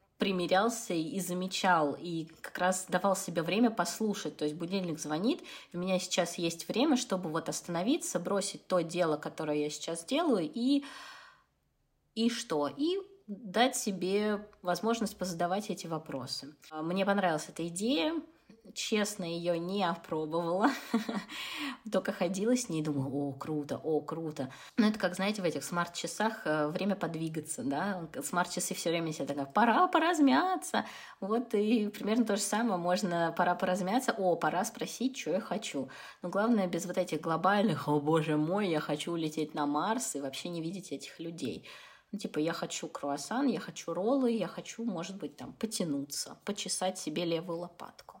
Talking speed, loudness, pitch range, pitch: 160 wpm, -32 LUFS, 165-215 Hz, 180 Hz